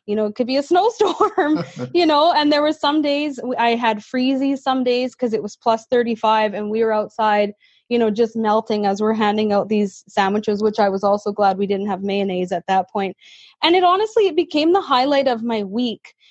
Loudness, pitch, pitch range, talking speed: -19 LUFS, 225 Hz, 210-280 Hz, 220 wpm